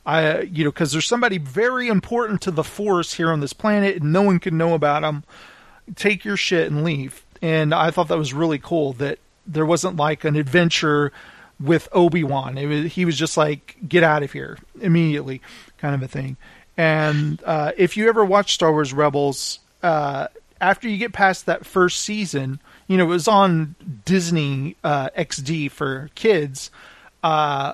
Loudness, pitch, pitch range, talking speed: -20 LUFS, 160 Hz, 150-185 Hz, 185 wpm